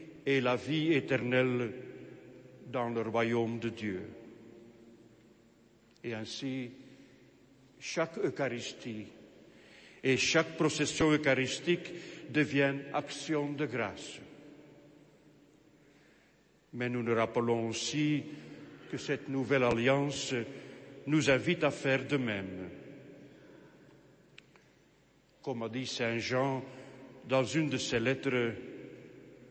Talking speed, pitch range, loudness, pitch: 95 wpm, 115-145 Hz, -32 LUFS, 130 Hz